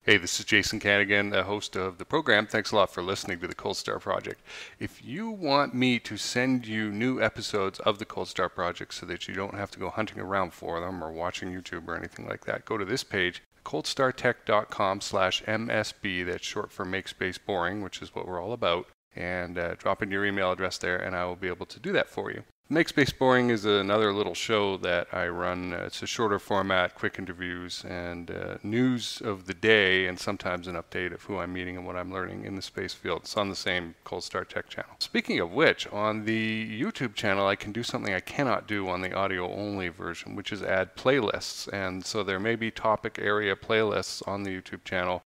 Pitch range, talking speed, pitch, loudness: 90-110 Hz, 225 wpm, 100 Hz, -29 LUFS